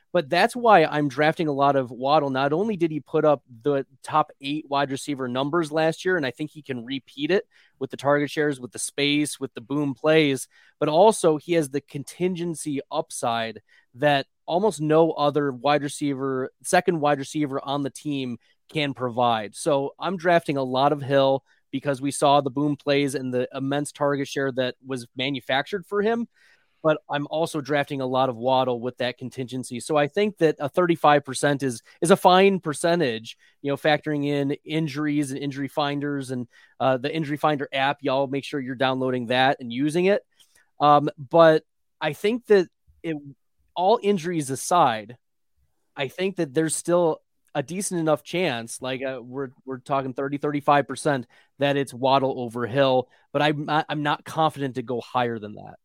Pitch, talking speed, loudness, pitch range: 145 Hz, 185 wpm, -24 LUFS, 135-155 Hz